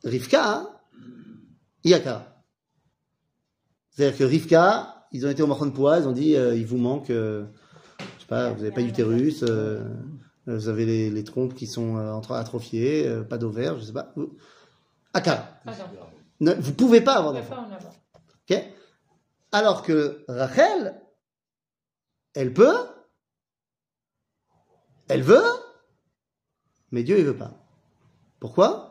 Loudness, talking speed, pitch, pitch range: -23 LUFS, 145 wpm, 130 Hz, 115-155 Hz